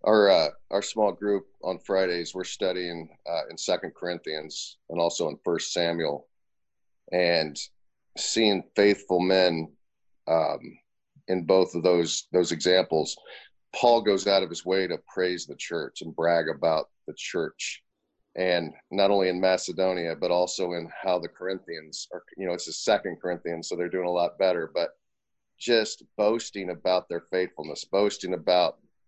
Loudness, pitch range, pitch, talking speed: -26 LUFS, 85-95 Hz, 90 Hz, 155 wpm